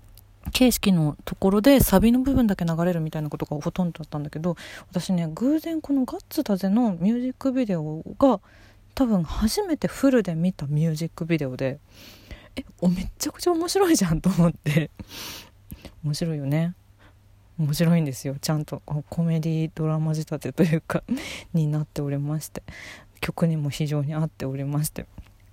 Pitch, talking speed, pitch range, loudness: 160 Hz, 350 characters per minute, 140-195 Hz, -24 LUFS